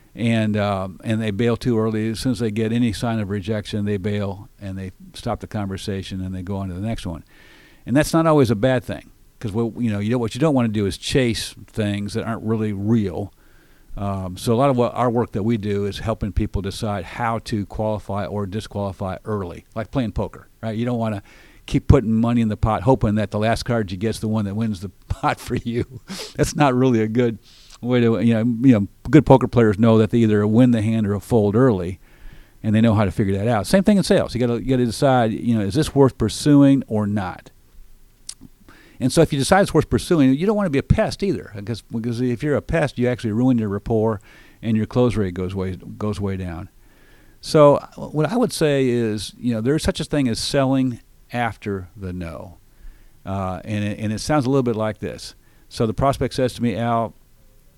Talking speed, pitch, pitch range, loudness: 235 wpm, 110 Hz, 105-125 Hz, -20 LUFS